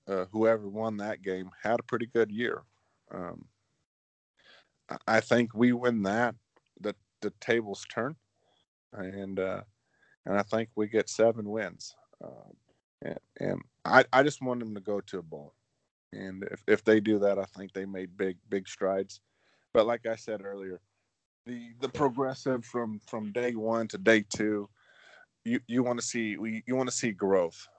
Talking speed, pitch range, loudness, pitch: 175 wpm, 100-120 Hz, -30 LUFS, 110 Hz